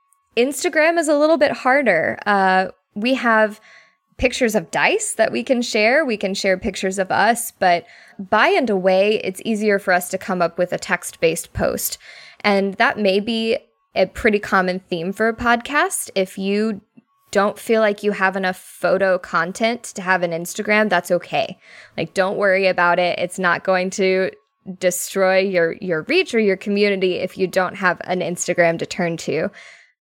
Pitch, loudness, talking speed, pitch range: 200 Hz, -19 LUFS, 175 wpm, 185-225 Hz